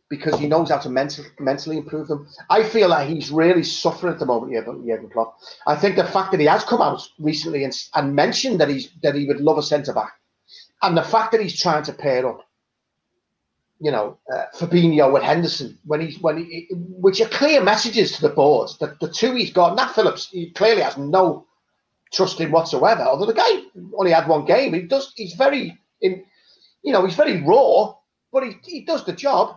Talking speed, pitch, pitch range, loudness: 215 wpm, 165 Hz, 150-210 Hz, -19 LUFS